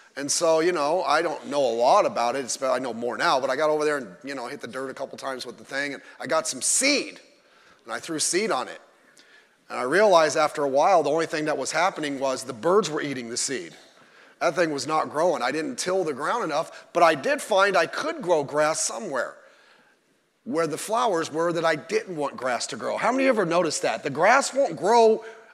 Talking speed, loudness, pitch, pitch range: 245 wpm, -24 LUFS, 155 Hz, 135-175 Hz